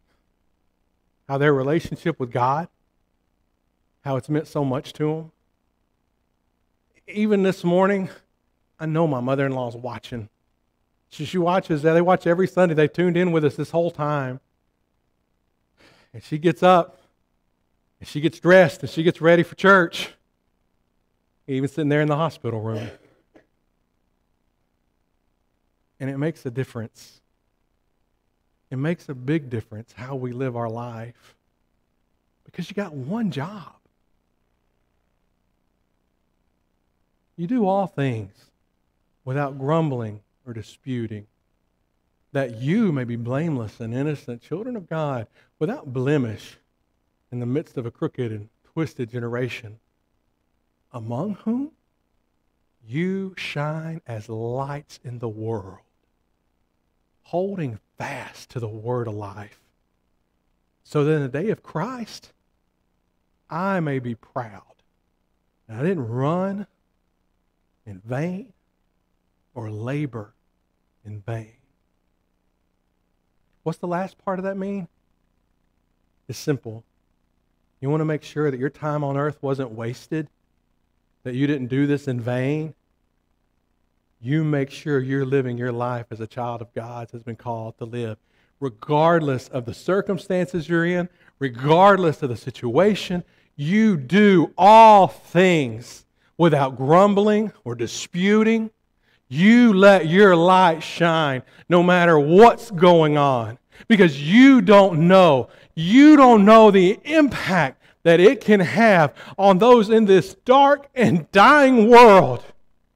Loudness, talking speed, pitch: -19 LUFS, 125 wpm, 130 Hz